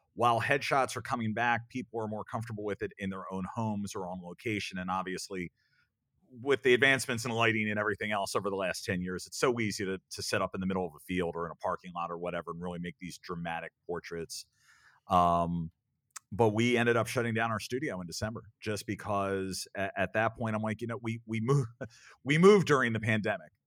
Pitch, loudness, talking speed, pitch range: 105 Hz, -31 LUFS, 225 wpm, 90-120 Hz